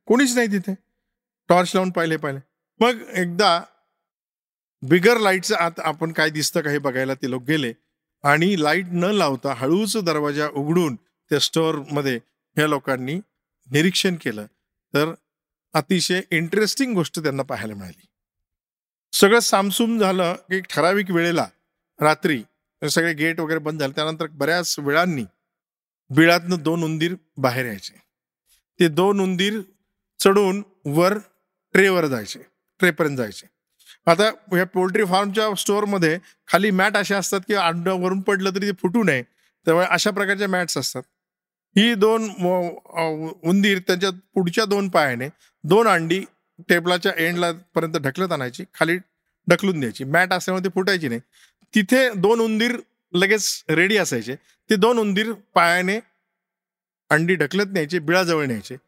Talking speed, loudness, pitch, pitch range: 130 wpm, -20 LUFS, 175 Hz, 155-195 Hz